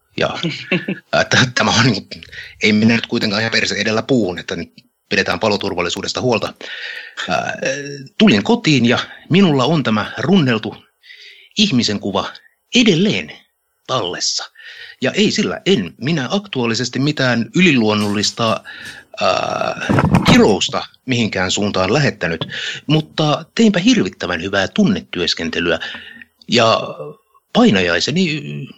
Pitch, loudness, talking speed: 140 Hz, -16 LUFS, 100 wpm